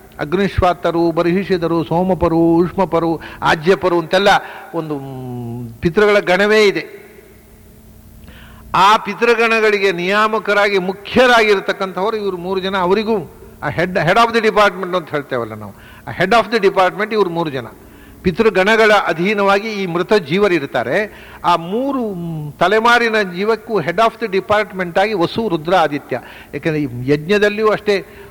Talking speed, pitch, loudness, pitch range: 115 wpm, 190 Hz, -15 LUFS, 165-210 Hz